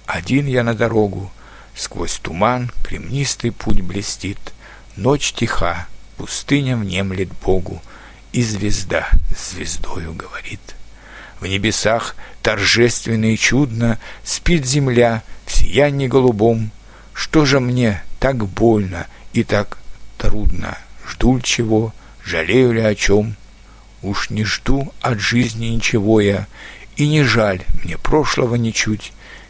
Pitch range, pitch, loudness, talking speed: 100-120 Hz, 110 Hz, -18 LUFS, 115 wpm